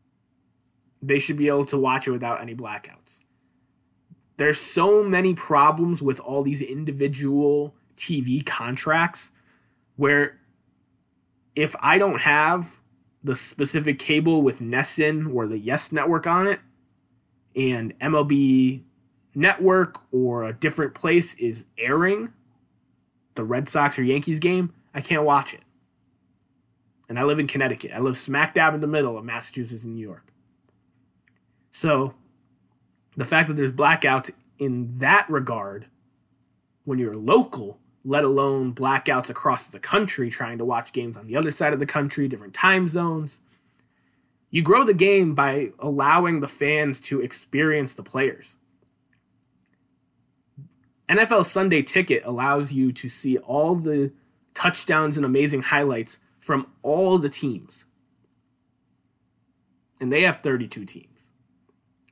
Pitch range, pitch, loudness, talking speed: 130-155 Hz, 140 Hz, -22 LUFS, 135 wpm